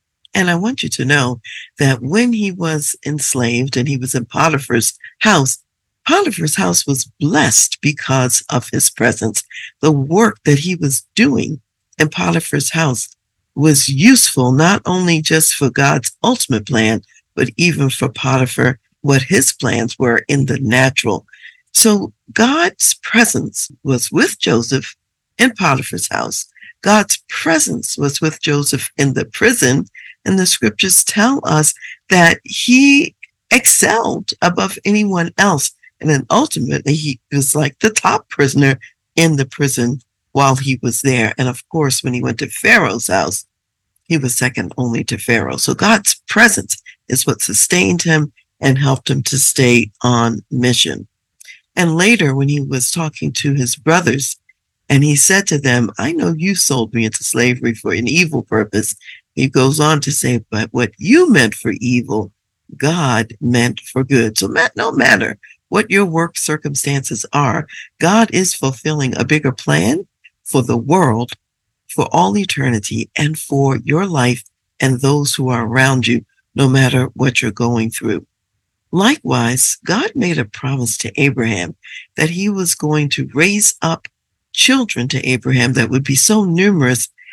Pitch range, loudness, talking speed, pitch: 120-160 Hz, -14 LUFS, 155 wpm, 135 Hz